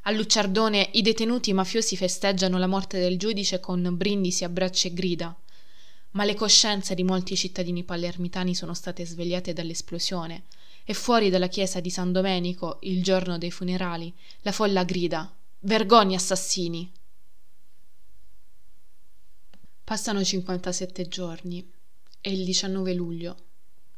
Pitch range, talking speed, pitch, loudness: 180-195 Hz, 125 wpm, 185 Hz, -25 LUFS